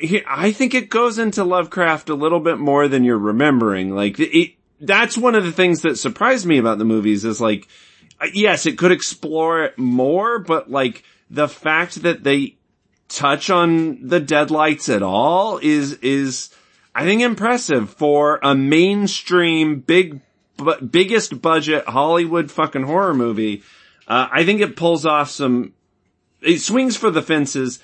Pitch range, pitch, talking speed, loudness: 140-185 Hz, 160 Hz, 160 wpm, -17 LUFS